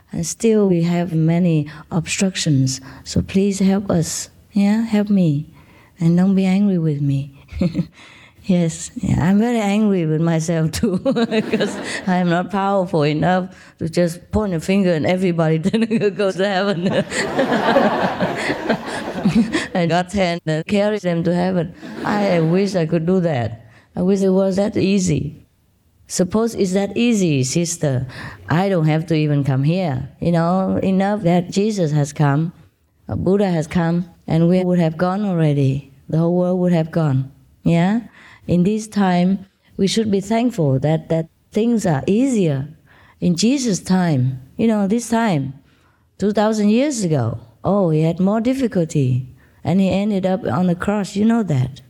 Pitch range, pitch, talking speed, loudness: 155-200 Hz, 180 Hz, 155 wpm, -18 LUFS